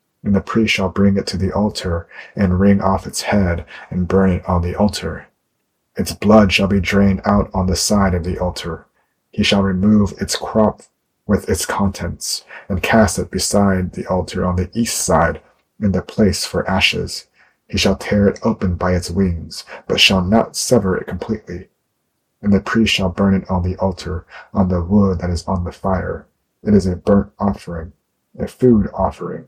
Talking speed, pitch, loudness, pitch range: 190 wpm, 95 Hz, -17 LUFS, 90-100 Hz